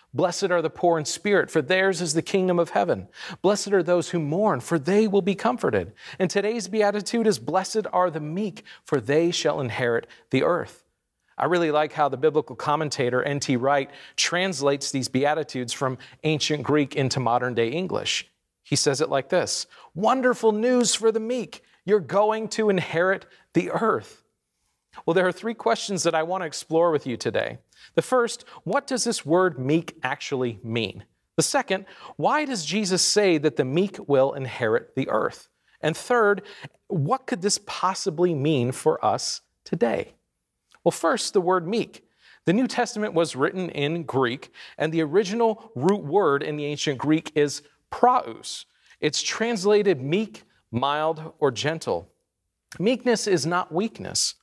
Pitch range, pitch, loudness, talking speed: 145-205 Hz, 175 Hz, -24 LUFS, 165 wpm